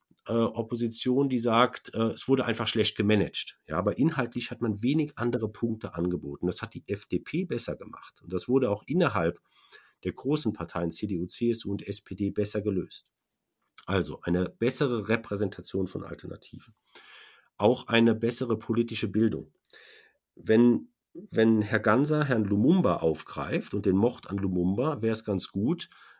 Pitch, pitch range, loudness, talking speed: 110 Hz, 100-120 Hz, -28 LUFS, 145 wpm